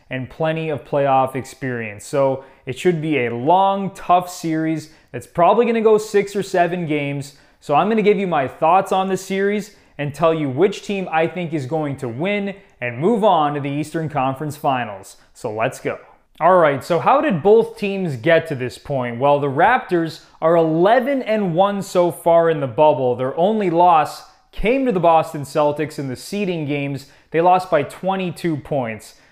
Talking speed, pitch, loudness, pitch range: 190 wpm, 160 Hz, -18 LUFS, 140-190 Hz